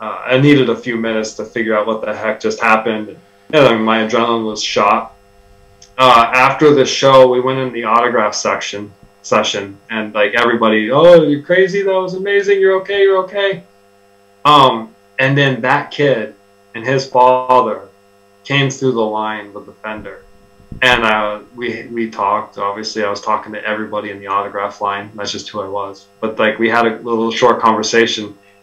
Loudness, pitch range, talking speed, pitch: -14 LUFS, 100-130 Hz, 180 wpm, 110 Hz